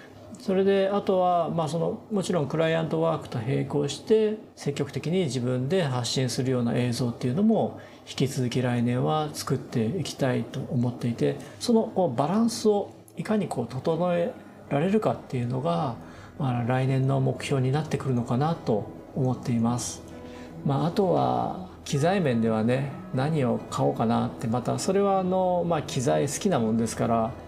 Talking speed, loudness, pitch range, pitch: 350 characters per minute, -26 LUFS, 125-175 Hz, 135 Hz